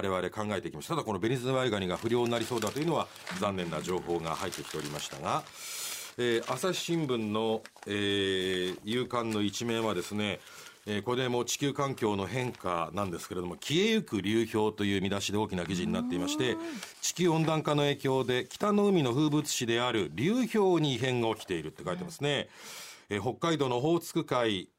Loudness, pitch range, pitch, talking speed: -31 LUFS, 105-150 Hz, 120 Hz, 410 characters per minute